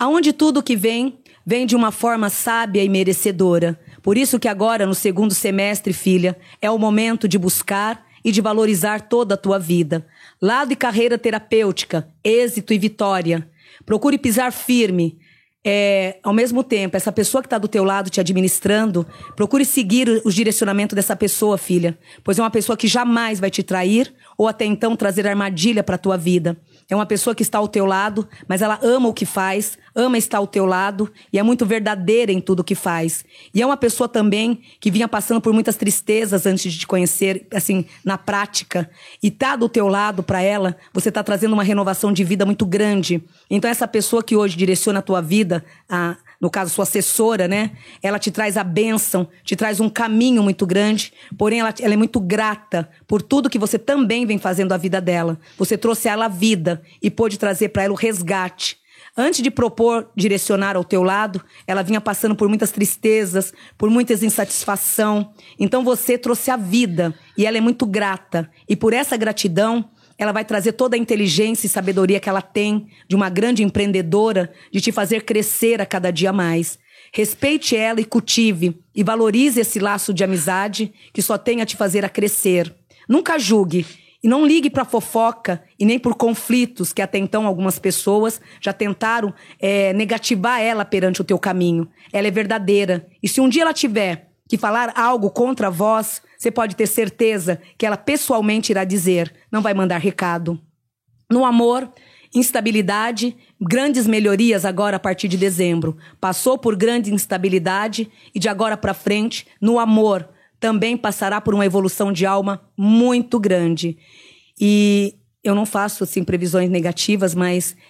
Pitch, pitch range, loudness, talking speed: 210 Hz, 190-225 Hz, -18 LUFS, 180 wpm